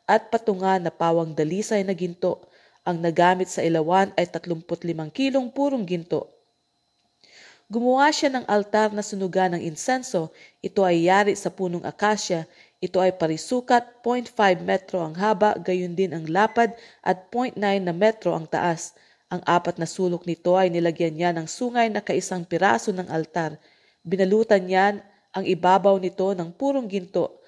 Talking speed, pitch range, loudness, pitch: 155 wpm, 175-210 Hz, -23 LUFS, 190 Hz